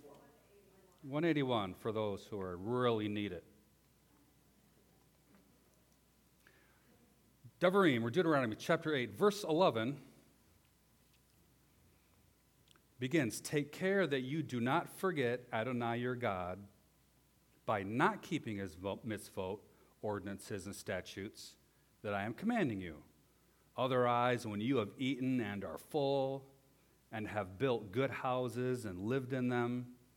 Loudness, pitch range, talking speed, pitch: -37 LUFS, 105-140 Hz, 110 wpm, 125 Hz